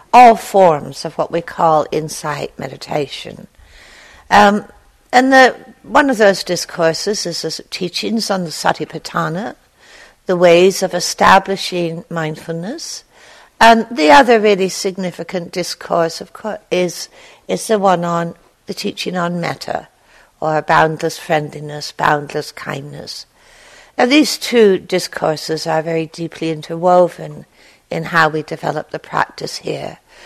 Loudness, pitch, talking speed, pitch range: -15 LUFS, 175 Hz, 125 wpm, 160-200 Hz